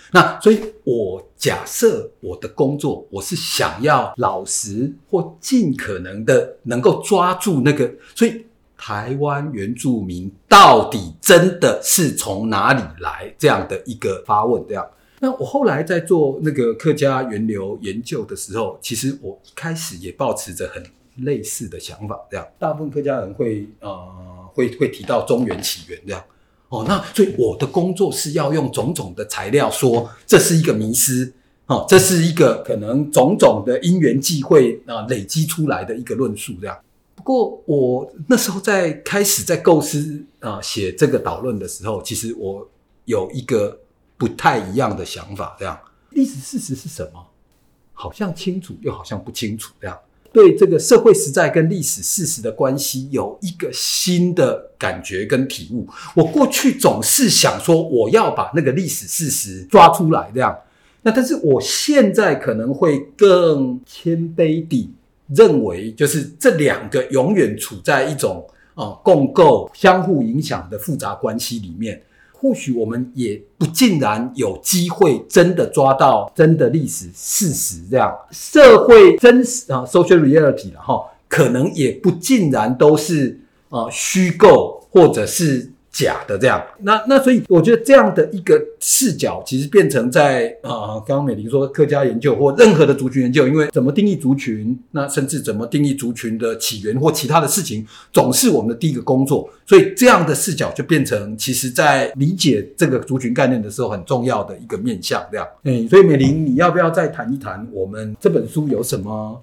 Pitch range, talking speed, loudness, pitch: 125-195 Hz, 270 characters per minute, -16 LUFS, 150 Hz